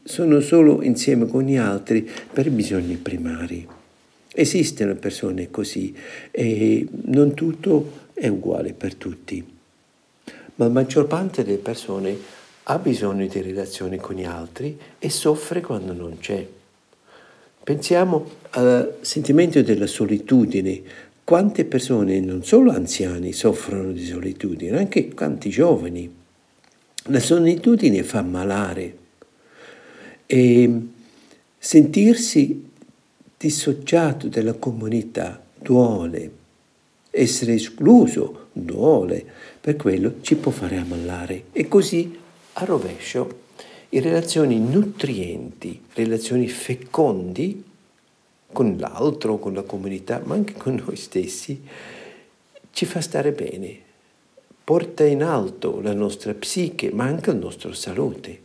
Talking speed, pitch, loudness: 110 wpm, 125 Hz, -20 LUFS